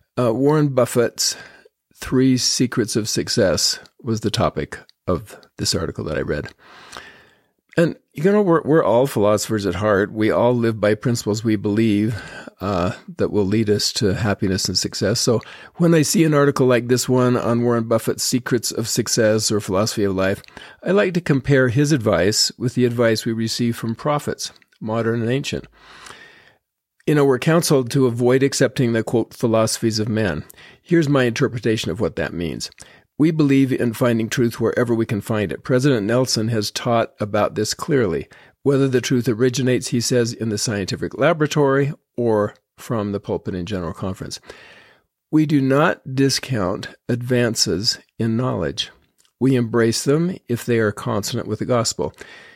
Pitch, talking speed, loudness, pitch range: 120 Hz, 165 wpm, -19 LUFS, 110-135 Hz